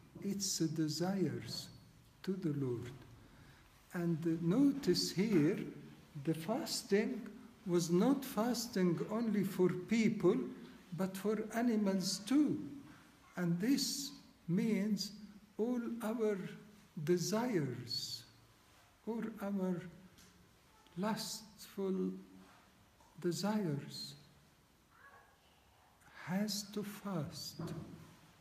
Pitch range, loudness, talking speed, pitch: 165-215 Hz, -37 LUFS, 70 wpm, 190 Hz